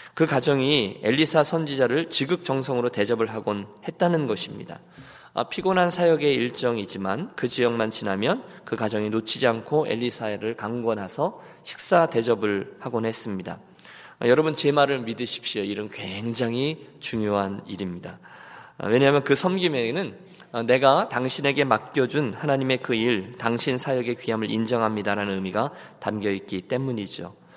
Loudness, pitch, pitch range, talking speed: -24 LUFS, 120 Hz, 110-140 Hz, 320 characters per minute